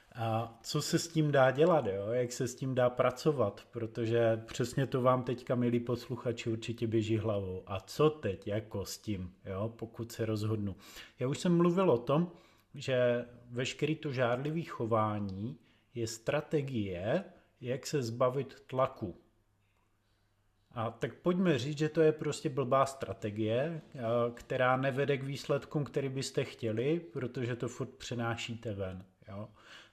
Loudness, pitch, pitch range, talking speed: -33 LUFS, 120 Hz, 110-140 Hz, 150 wpm